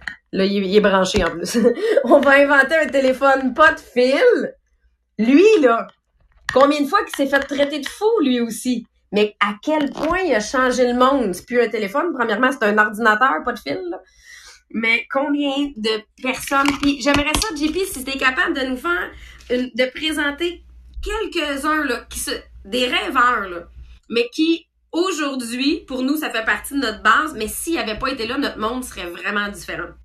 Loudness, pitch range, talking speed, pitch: -18 LUFS, 230-305 Hz, 190 wpm, 265 Hz